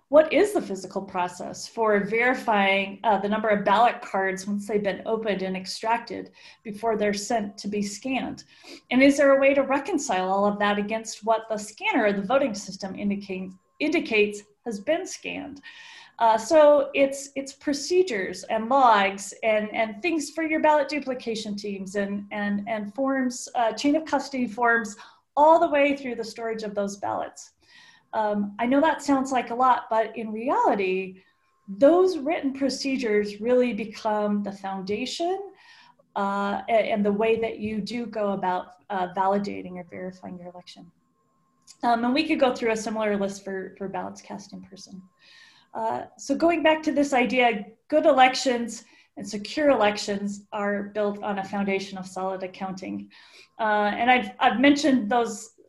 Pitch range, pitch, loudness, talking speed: 205-275 Hz, 225 Hz, -24 LUFS, 165 wpm